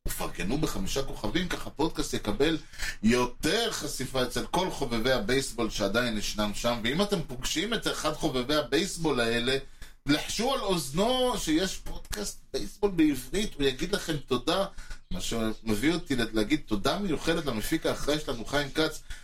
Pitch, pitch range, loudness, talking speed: 140 Hz, 120-160 Hz, -29 LUFS, 140 wpm